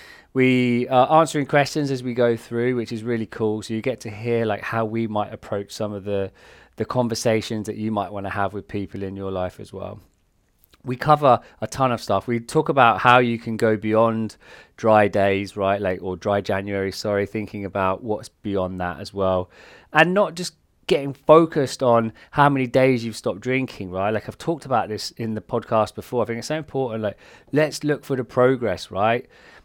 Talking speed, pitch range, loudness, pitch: 210 wpm, 100-130 Hz, -22 LUFS, 110 Hz